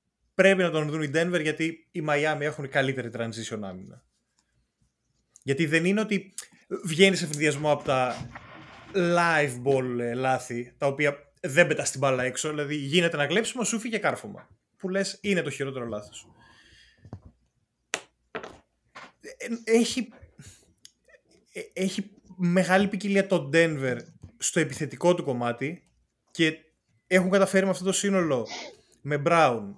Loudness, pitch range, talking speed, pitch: -26 LUFS, 135-190 Hz, 130 wpm, 155 Hz